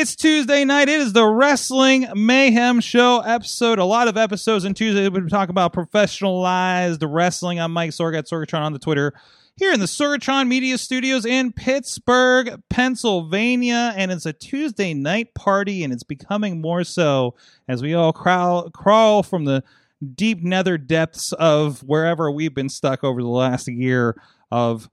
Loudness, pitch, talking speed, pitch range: -19 LUFS, 190 Hz, 165 wpm, 160-240 Hz